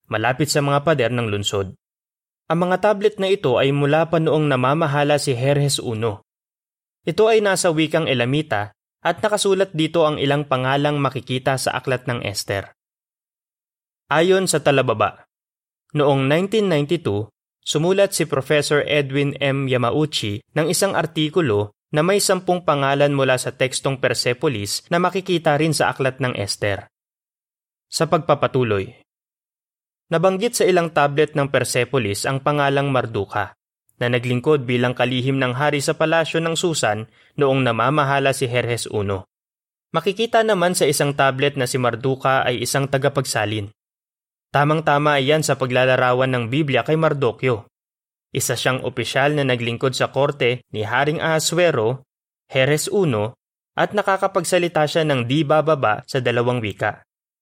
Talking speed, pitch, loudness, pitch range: 135 wpm, 140 Hz, -19 LUFS, 125-160 Hz